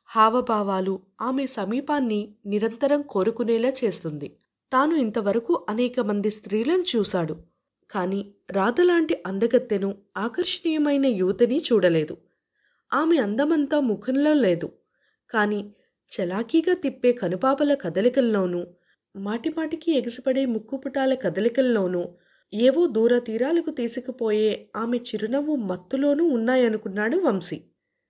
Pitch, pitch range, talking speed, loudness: 235 Hz, 200-275 Hz, 85 wpm, -24 LUFS